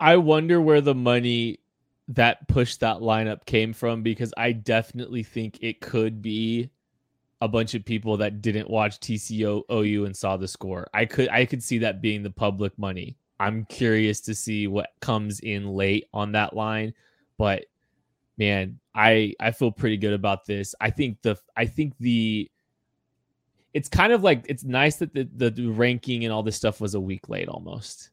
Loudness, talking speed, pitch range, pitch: -24 LUFS, 185 wpm, 105-120 Hz, 110 Hz